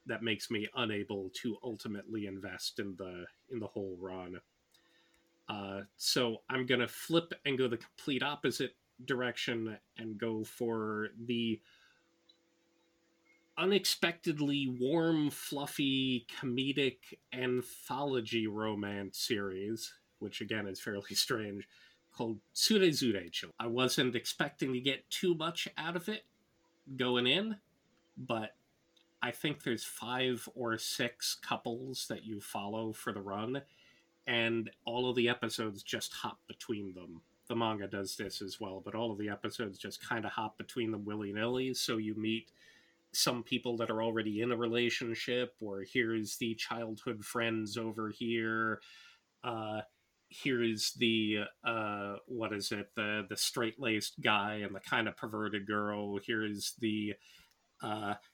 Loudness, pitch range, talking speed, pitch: -36 LUFS, 105-125 Hz, 135 wpm, 115 Hz